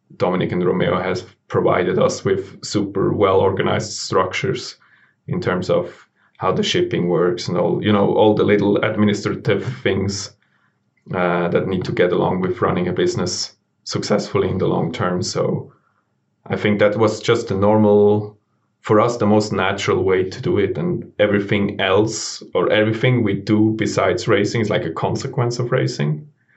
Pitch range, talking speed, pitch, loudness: 100-110 Hz, 165 wpm, 105 Hz, -19 LUFS